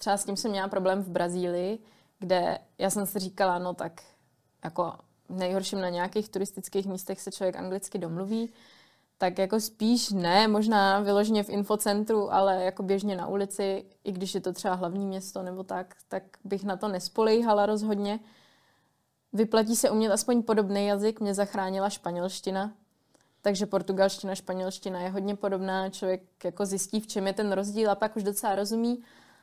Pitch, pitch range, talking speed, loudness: 200 Hz, 190-210 Hz, 165 wpm, -29 LUFS